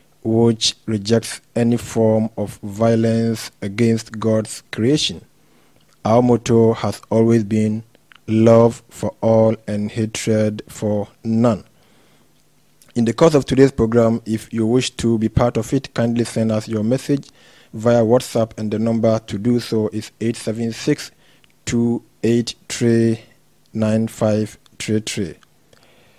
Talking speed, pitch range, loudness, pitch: 135 wpm, 110-120 Hz, -18 LUFS, 115 Hz